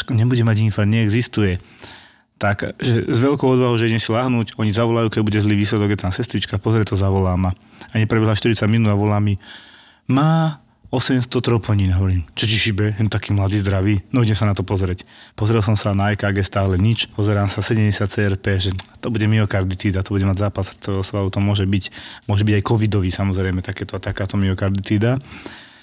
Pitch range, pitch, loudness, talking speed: 100-115 Hz, 105 Hz, -19 LUFS, 190 wpm